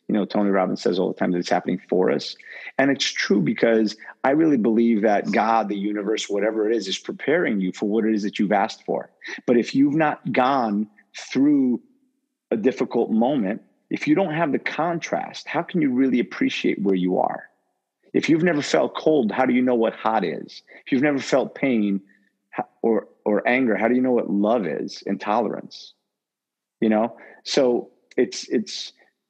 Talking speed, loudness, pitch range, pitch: 195 wpm, -22 LUFS, 100-135 Hz, 110 Hz